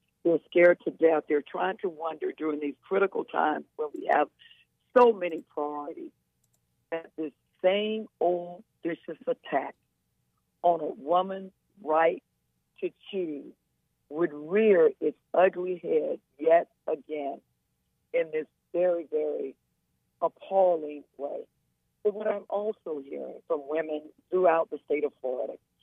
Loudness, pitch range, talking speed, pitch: -28 LUFS, 155-215 Hz, 130 wpm, 175 Hz